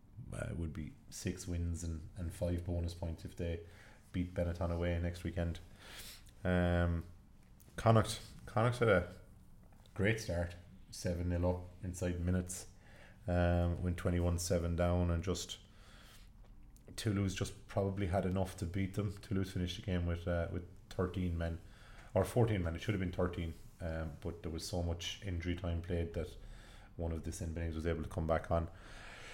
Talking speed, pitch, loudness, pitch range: 170 wpm, 90 Hz, -38 LUFS, 85-100 Hz